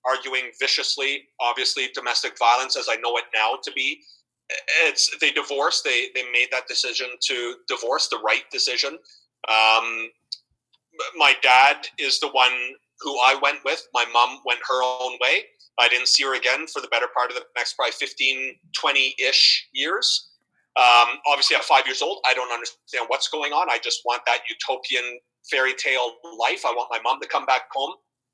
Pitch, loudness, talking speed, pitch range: 125 Hz, -21 LUFS, 180 wpm, 120-145 Hz